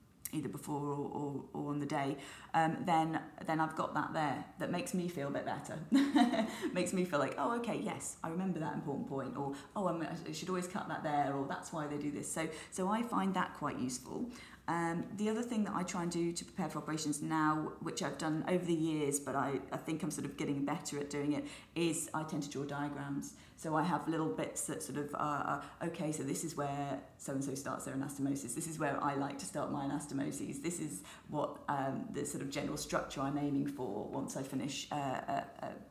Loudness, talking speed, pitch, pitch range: -38 LUFS, 235 wpm, 155 Hz, 140-170 Hz